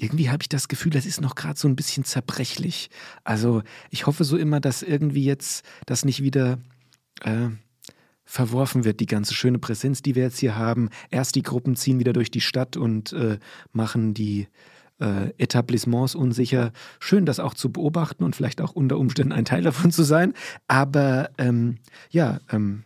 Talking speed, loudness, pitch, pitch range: 185 wpm, -23 LUFS, 130 Hz, 120-145 Hz